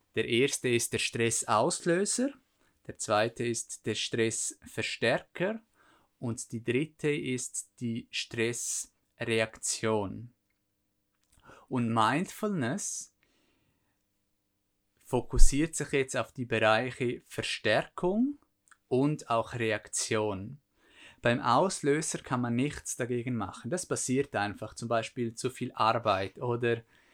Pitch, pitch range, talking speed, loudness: 120 Hz, 110-140 Hz, 95 wpm, -31 LUFS